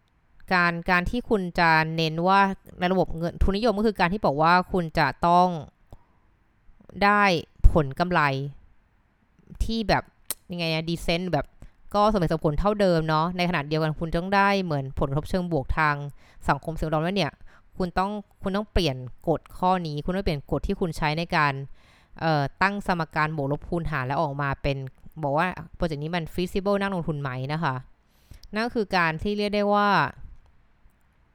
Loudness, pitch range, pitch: -25 LUFS, 150-185 Hz, 170 Hz